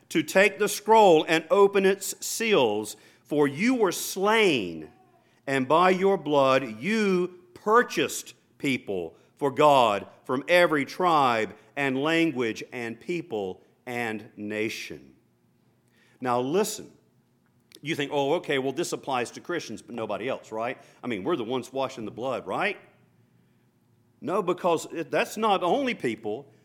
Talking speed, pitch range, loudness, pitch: 135 wpm, 120-180 Hz, -25 LUFS, 150 Hz